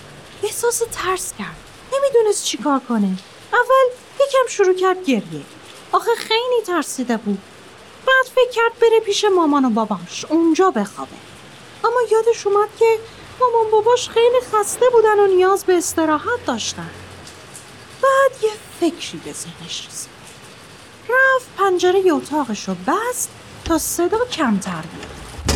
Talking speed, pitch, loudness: 130 wpm, 375 Hz, -18 LUFS